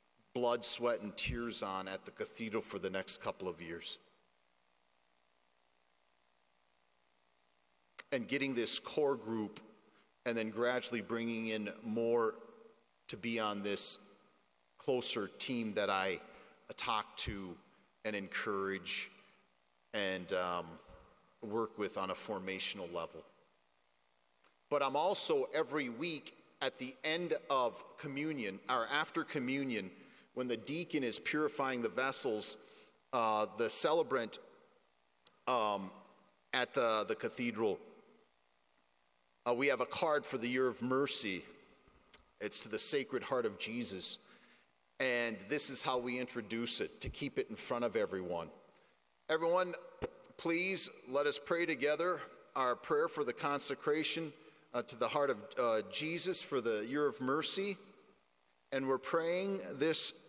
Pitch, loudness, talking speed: 115 Hz, -37 LUFS, 130 wpm